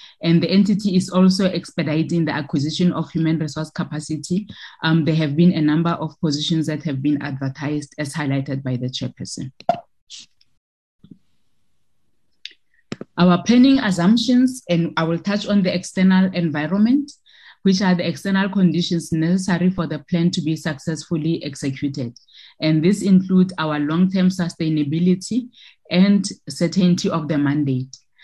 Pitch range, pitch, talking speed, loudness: 155-185 Hz, 170 Hz, 140 wpm, -19 LUFS